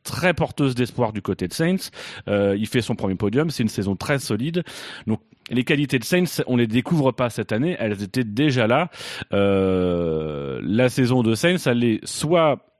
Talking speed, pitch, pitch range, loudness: 195 wpm, 125 Hz, 105-145 Hz, -22 LUFS